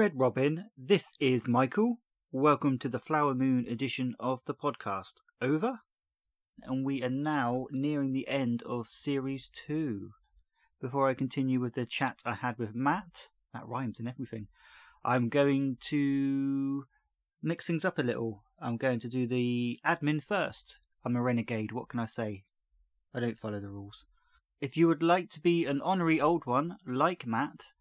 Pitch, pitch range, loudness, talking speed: 130 Hz, 120-145 Hz, -32 LUFS, 170 wpm